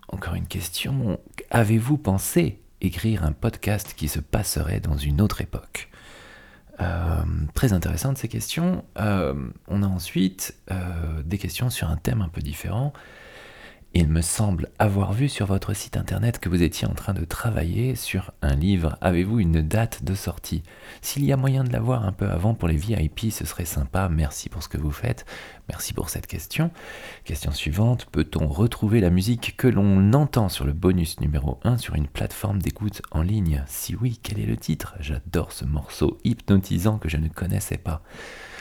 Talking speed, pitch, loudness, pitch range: 180 wpm, 95 Hz, -25 LUFS, 80-110 Hz